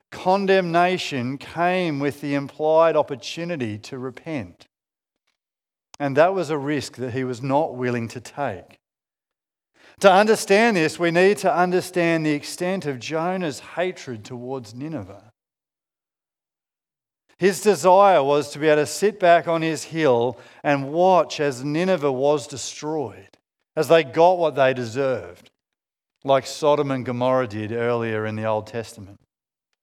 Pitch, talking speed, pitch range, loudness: 145 Hz, 135 wpm, 130-175 Hz, -21 LUFS